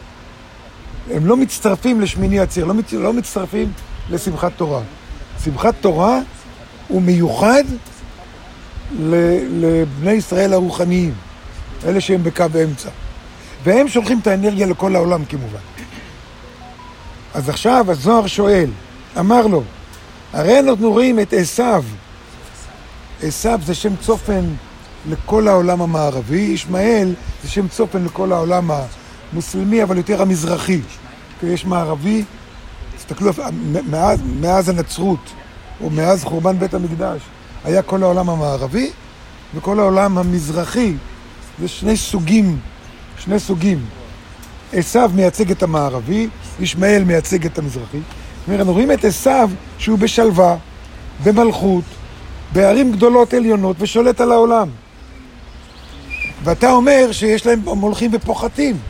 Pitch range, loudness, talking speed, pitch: 155-210 Hz, -16 LUFS, 115 wpm, 185 Hz